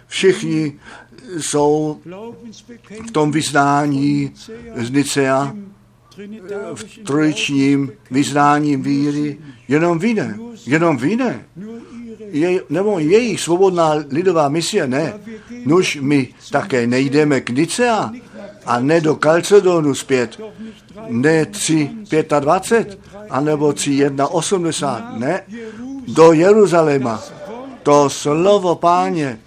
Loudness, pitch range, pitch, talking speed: -16 LUFS, 145-210 Hz, 160 Hz, 90 wpm